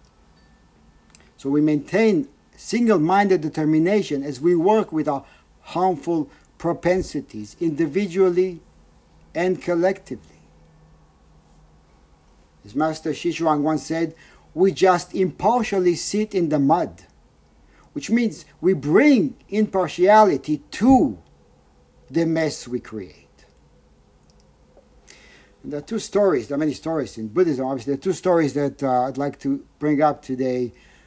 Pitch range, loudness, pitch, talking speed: 125-185 Hz, -21 LUFS, 155 Hz, 120 wpm